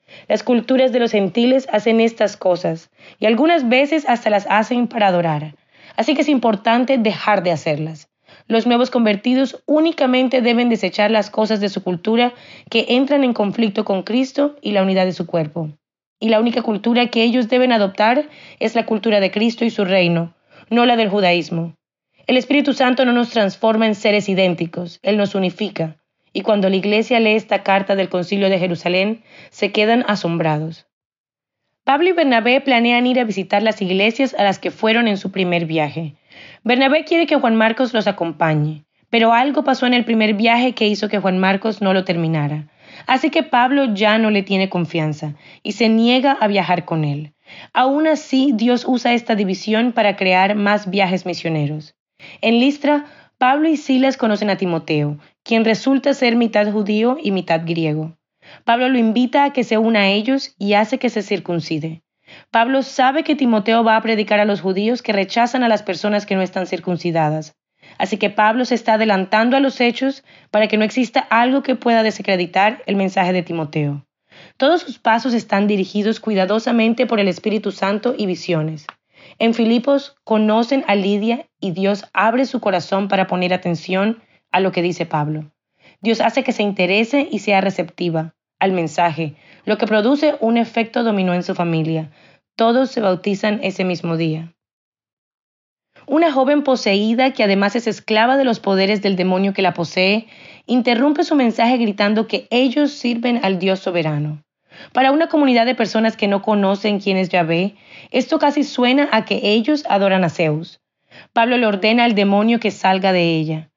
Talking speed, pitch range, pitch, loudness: 175 wpm, 185-245 Hz, 215 Hz, -17 LUFS